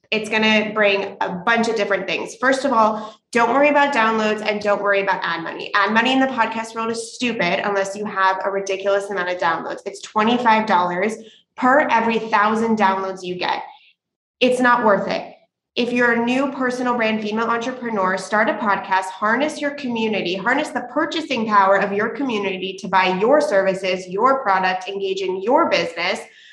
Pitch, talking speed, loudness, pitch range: 220 Hz, 185 wpm, -19 LUFS, 195-245 Hz